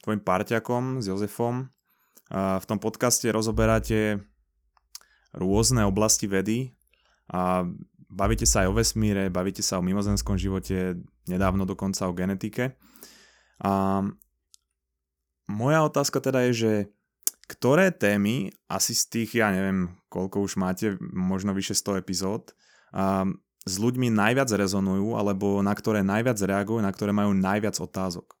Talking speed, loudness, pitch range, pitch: 130 wpm, -26 LUFS, 95-110 Hz, 100 Hz